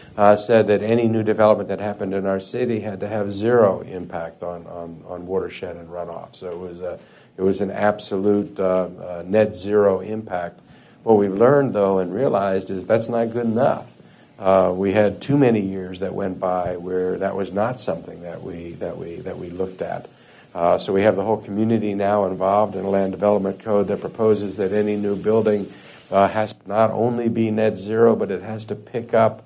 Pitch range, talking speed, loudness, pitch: 95-110 Hz, 210 wpm, -20 LUFS, 100 Hz